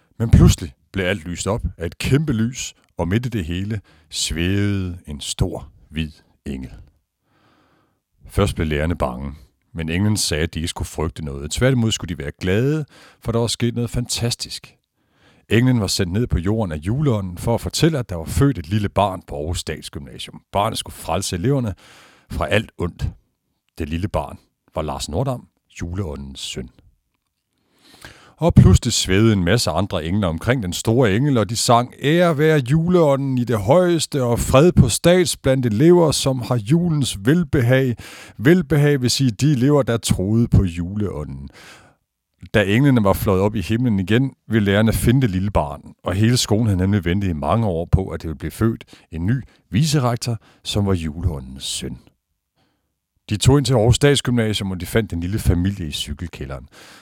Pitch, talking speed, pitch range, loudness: 105 Hz, 175 wpm, 85-125 Hz, -19 LUFS